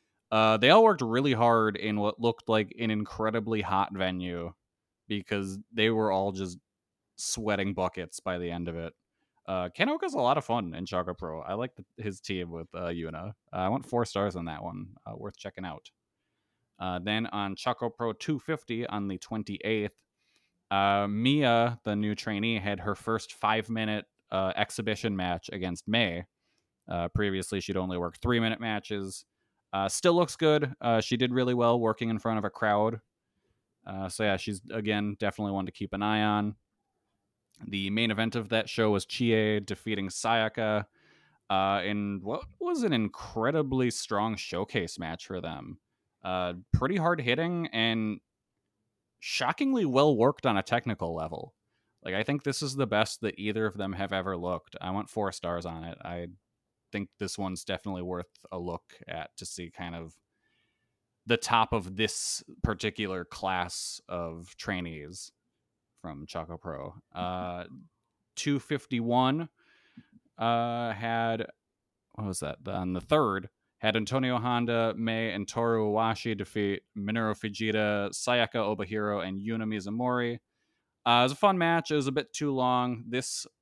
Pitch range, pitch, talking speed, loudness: 95-115 Hz, 105 Hz, 165 wpm, -30 LUFS